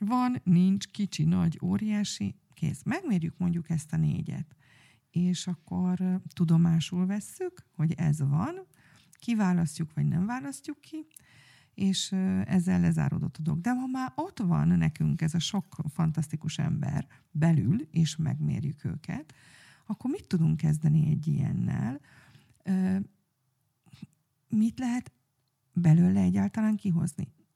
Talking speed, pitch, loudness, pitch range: 115 wpm, 170 Hz, -29 LUFS, 155-195 Hz